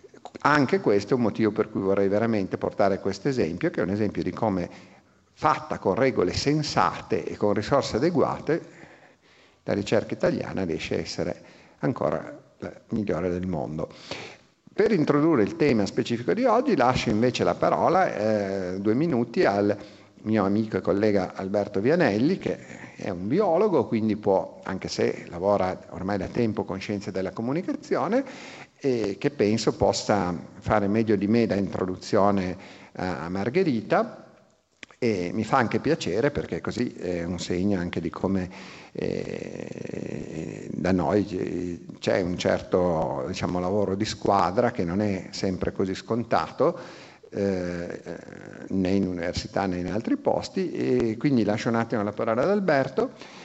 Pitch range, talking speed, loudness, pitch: 95-110 Hz, 150 wpm, -25 LUFS, 100 Hz